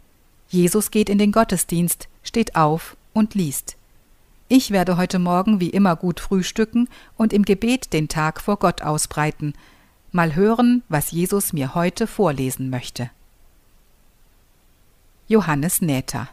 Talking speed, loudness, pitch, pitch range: 130 wpm, -20 LUFS, 175 Hz, 130-205 Hz